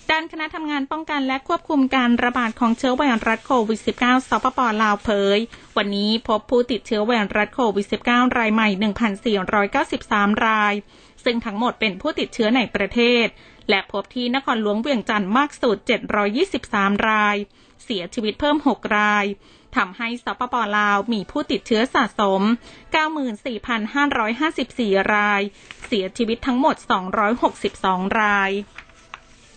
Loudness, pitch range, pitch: -20 LUFS, 210-260 Hz, 230 Hz